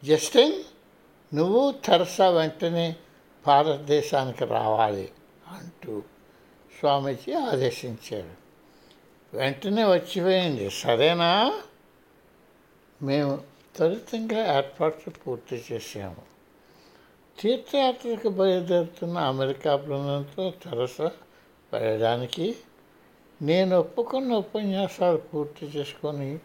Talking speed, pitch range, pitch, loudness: 65 wpm, 140-190 Hz, 160 Hz, -25 LUFS